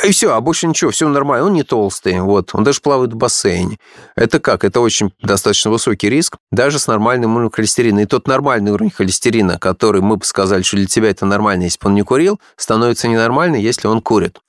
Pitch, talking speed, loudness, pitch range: 110 Hz, 215 wpm, -14 LUFS, 100-130 Hz